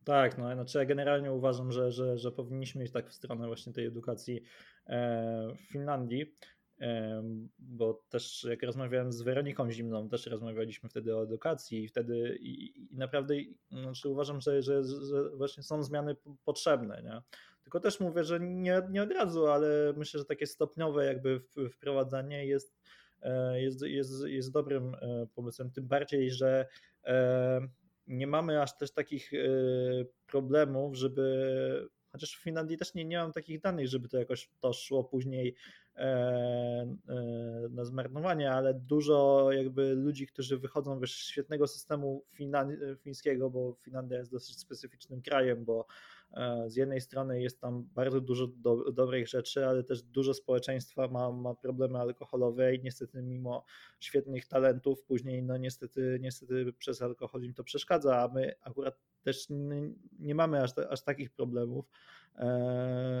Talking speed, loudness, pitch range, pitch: 145 wpm, -34 LUFS, 125-140 Hz, 130 Hz